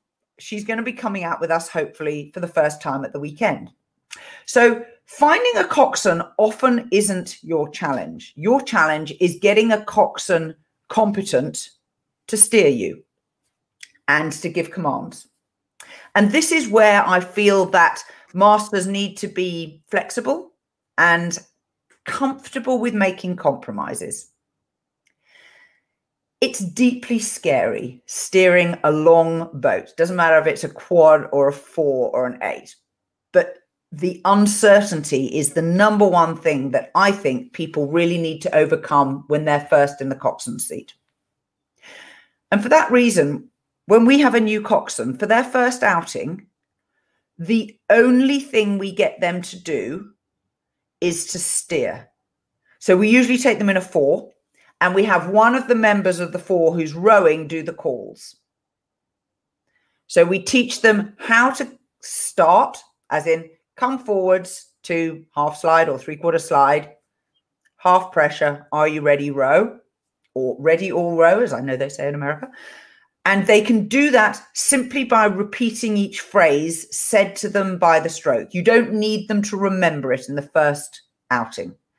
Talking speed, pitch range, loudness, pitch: 150 wpm, 160-220 Hz, -18 LUFS, 185 Hz